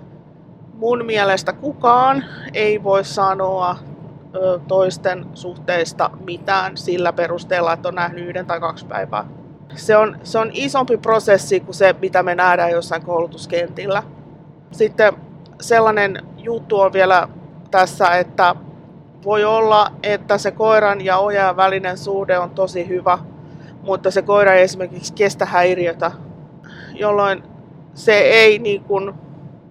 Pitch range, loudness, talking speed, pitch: 165-200 Hz, -17 LUFS, 125 wpm, 180 Hz